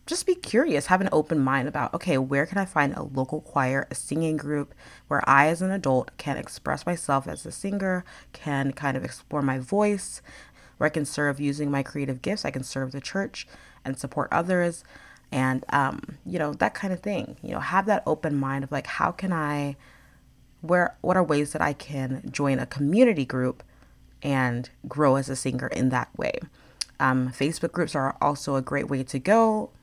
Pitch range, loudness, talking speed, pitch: 135-170 Hz, -26 LUFS, 200 wpm, 145 Hz